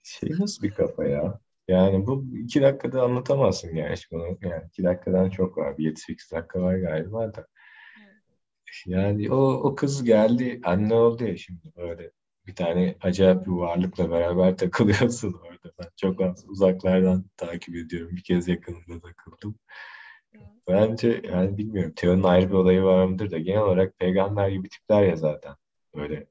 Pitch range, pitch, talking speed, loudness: 90-105 Hz, 95 Hz, 155 wpm, -24 LUFS